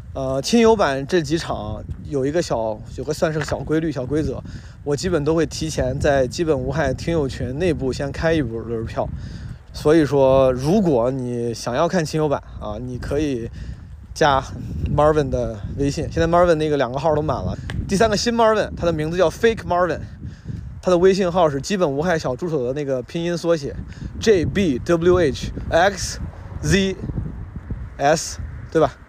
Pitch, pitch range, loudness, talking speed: 145 Hz, 125-170 Hz, -20 LUFS, 295 characters per minute